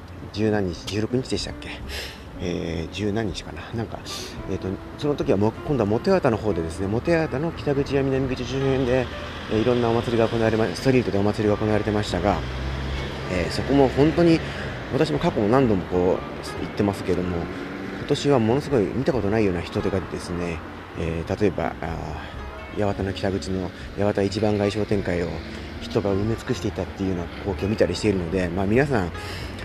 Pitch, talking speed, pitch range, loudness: 100 Hz, 385 characters per minute, 85-110 Hz, -24 LUFS